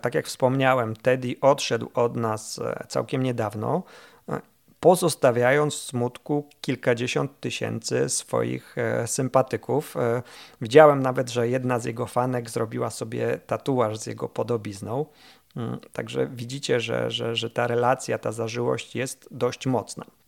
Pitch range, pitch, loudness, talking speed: 115-135 Hz, 125 Hz, -25 LUFS, 120 wpm